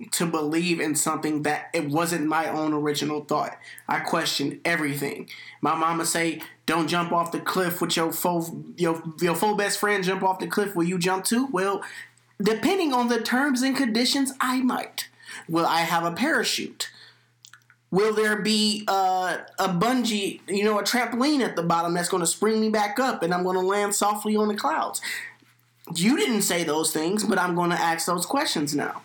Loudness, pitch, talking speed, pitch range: -24 LUFS, 180 Hz, 195 wpm, 165-215 Hz